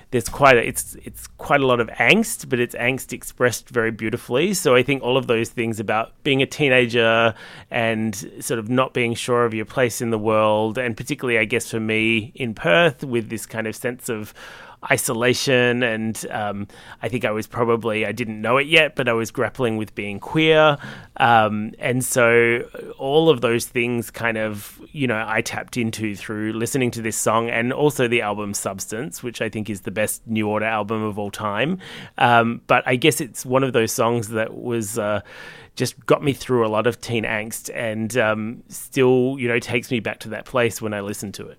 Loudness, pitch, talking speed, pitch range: -20 LUFS, 115 Hz, 215 wpm, 110-125 Hz